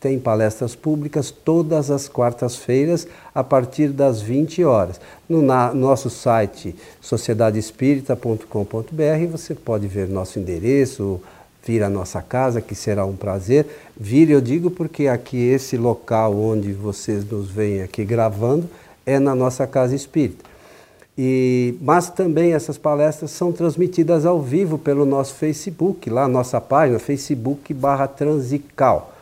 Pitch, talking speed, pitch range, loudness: 135 Hz, 130 wpm, 115-150 Hz, -19 LUFS